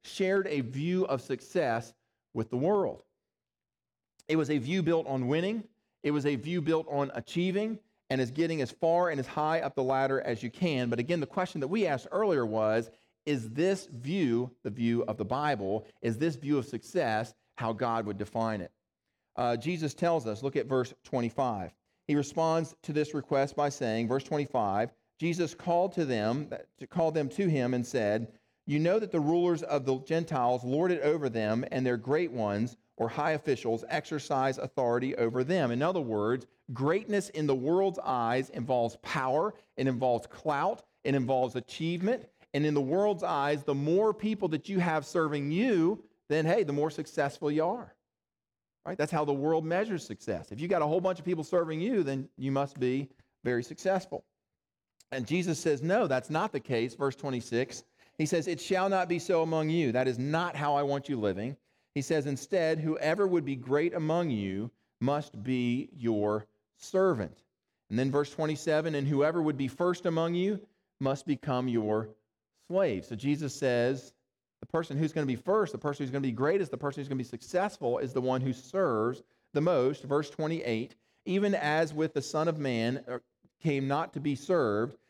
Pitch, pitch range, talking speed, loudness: 145 Hz, 125-165 Hz, 190 wpm, -31 LUFS